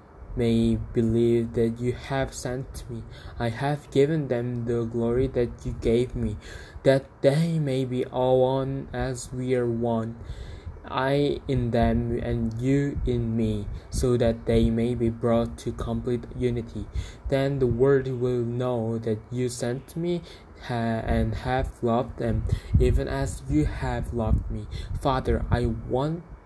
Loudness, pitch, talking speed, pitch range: -26 LUFS, 120 Hz, 145 wpm, 115-130 Hz